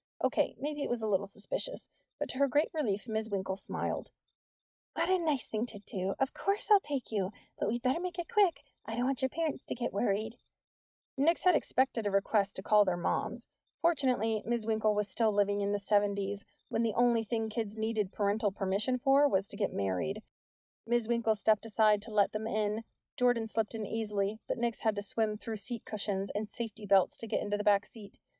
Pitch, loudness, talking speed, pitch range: 220 Hz, -32 LUFS, 210 wpm, 205-250 Hz